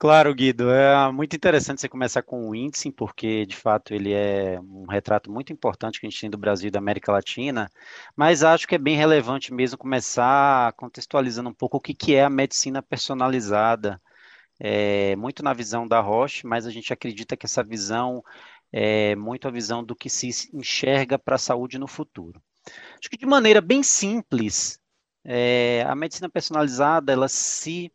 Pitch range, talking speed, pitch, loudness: 110-140 Hz, 180 wpm, 125 Hz, -22 LUFS